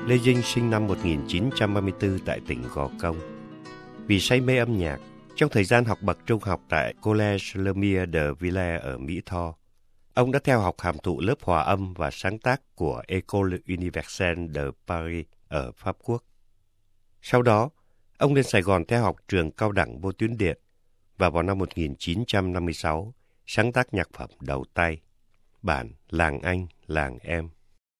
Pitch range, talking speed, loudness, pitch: 80-105 Hz, 165 wpm, -26 LUFS, 95 Hz